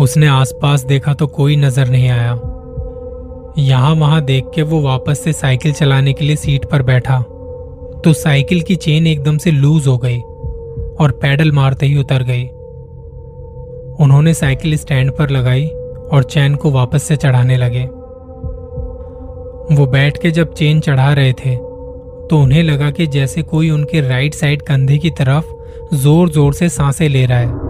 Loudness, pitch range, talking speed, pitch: -13 LUFS, 125-155 Hz, 165 wpm, 140 Hz